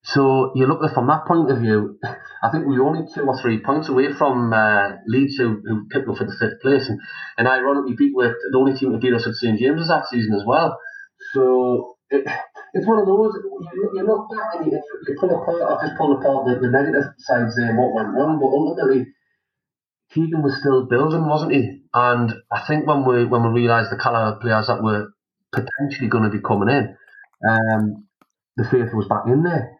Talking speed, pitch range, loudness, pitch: 215 wpm, 120-155 Hz, -19 LUFS, 130 Hz